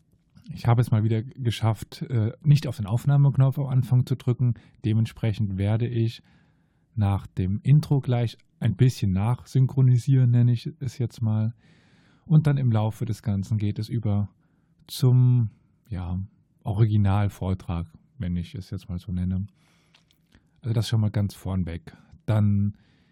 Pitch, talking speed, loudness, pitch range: 115 Hz, 145 wpm, -25 LUFS, 105-130 Hz